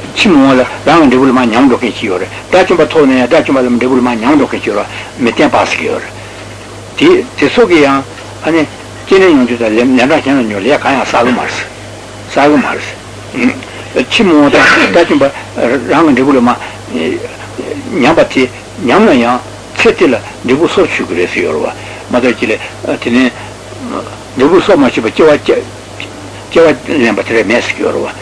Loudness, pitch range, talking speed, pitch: -9 LUFS, 110-135 Hz, 125 wpm, 125 Hz